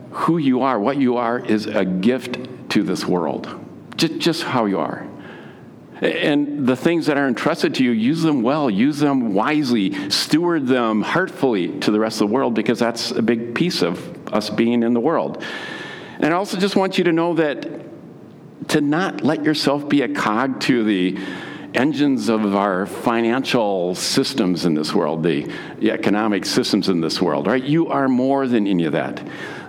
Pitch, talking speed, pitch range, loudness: 130 Hz, 185 wpm, 115-160 Hz, -19 LUFS